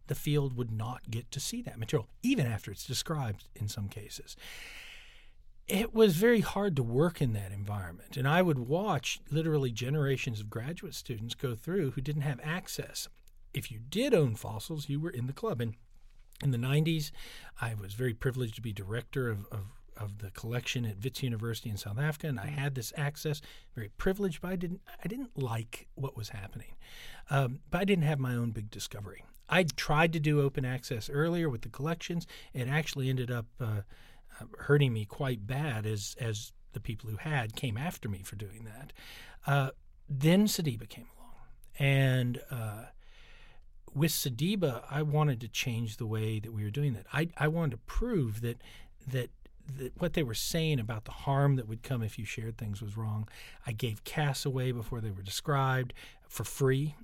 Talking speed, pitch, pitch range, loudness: 190 wpm, 130 Hz, 115-150 Hz, -33 LUFS